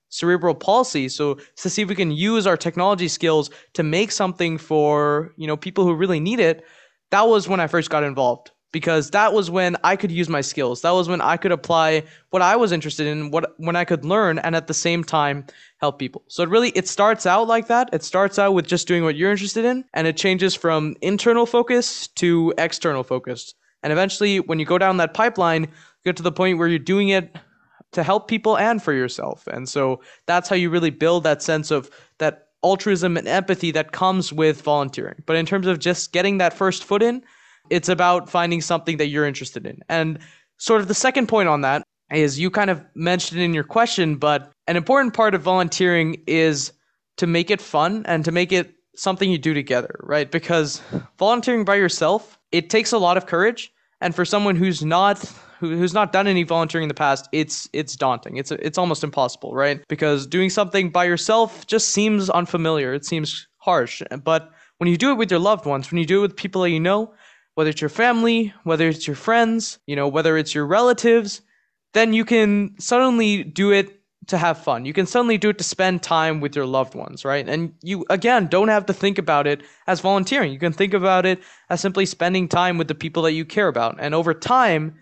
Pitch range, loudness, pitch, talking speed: 155-200 Hz, -20 LUFS, 175 Hz, 220 wpm